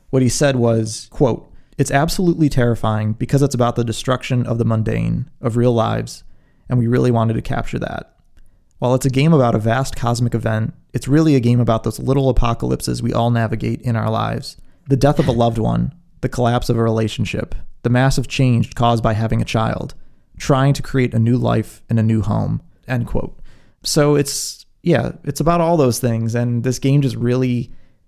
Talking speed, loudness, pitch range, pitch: 200 wpm, -18 LUFS, 115-135 Hz, 120 Hz